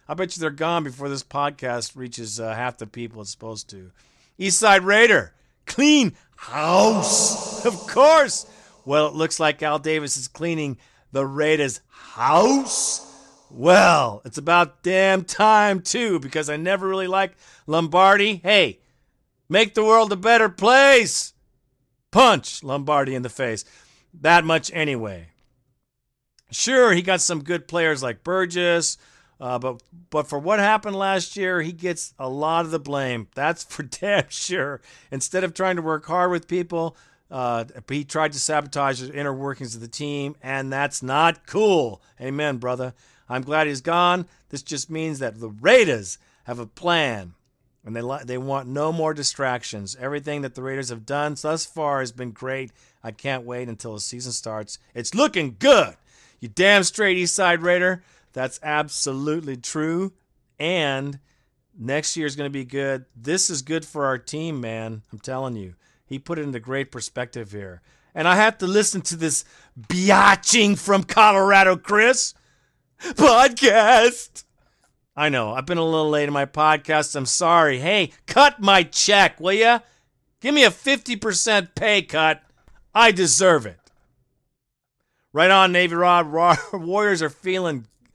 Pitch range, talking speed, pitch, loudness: 130-185 Hz, 160 wpm, 150 Hz, -20 LUFS